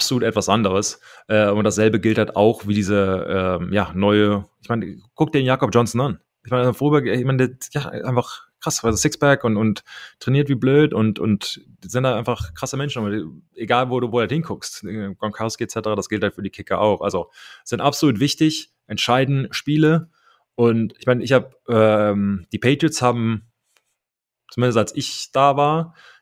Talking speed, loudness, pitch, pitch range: 185 wpm, -20 LUFS, 120 Hz, 105-135 Hz